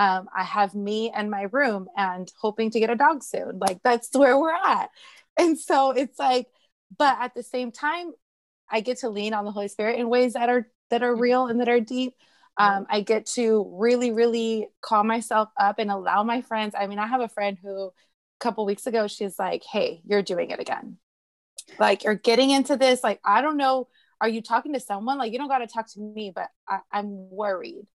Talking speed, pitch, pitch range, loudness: 225 wpm, 230 Hz, 205-255 Hz, -24 LUFS